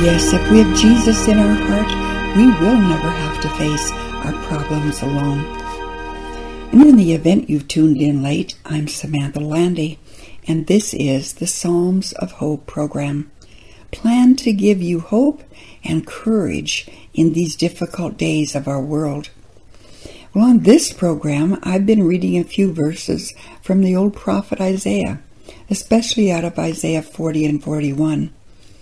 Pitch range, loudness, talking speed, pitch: 140-185 Hz, -16 LUFS, 150 wpm, 155 Hz